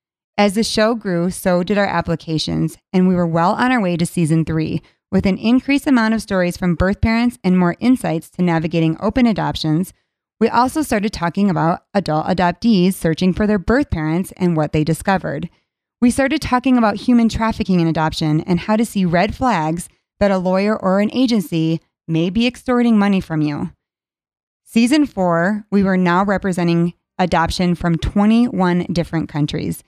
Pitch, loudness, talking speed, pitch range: 185 Hz, -17 LUFS, 175 wpm, 170-220 Hz